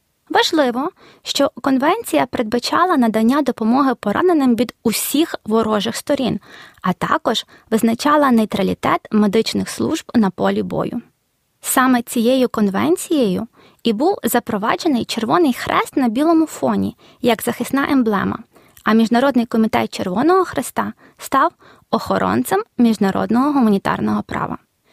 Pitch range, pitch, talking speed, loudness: 225-290 Hz, 245 Hz, 105 wpm, -17 LUFS